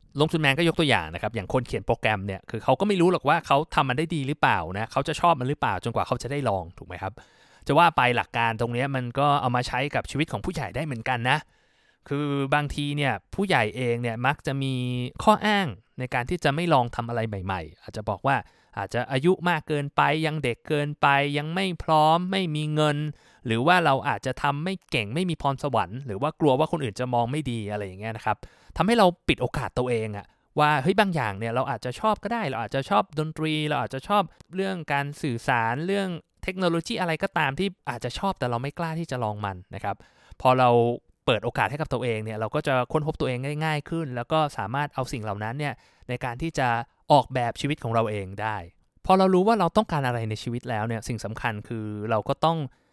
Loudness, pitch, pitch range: -25 LUFS, 135 Hz, 120-155 Hz